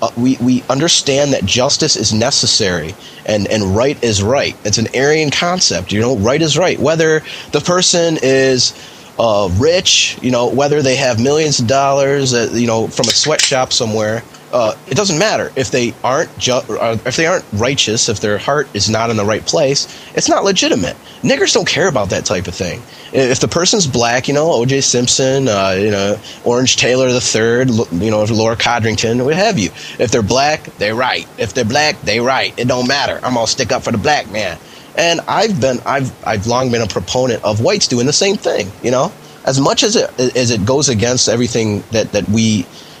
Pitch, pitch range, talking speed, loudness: 125 Hz, 110-140 Hz, 205 wpm, -13 LUFS